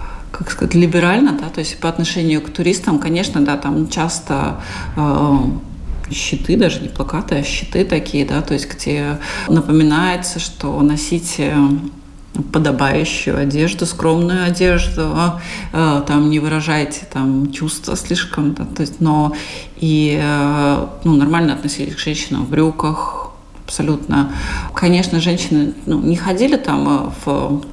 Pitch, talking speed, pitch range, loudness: 155 Hz, 135 wpm, 145-170 Hz, -16 LUFS